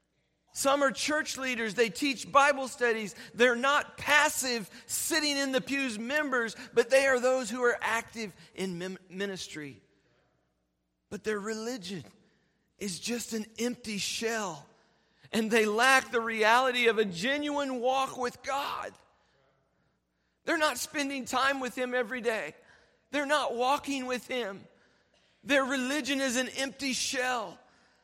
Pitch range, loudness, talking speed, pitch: 215-270 Hz, -29 LUFS, 135 wpm, 245 Hz